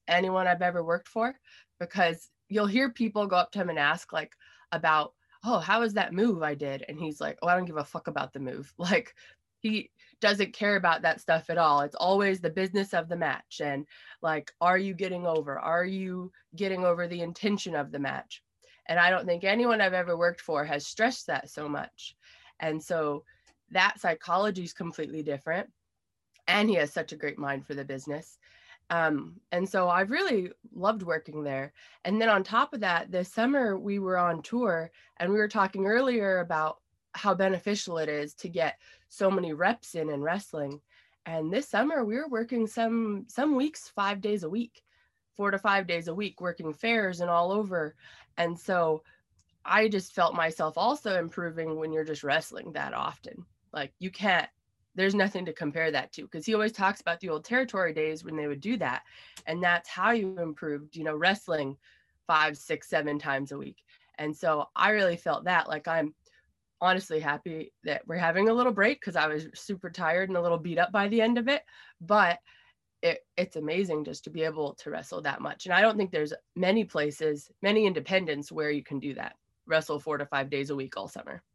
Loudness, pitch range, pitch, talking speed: -29 LUFS, 155-205 Hz, 175 Hz, 205 wpm